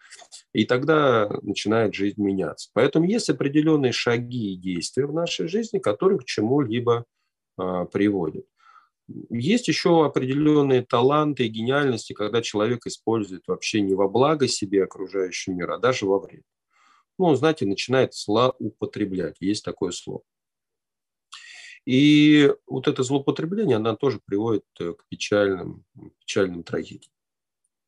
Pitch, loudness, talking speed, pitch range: 120 Hz, -23 LUFS, 125 wpm, 100-150 Hz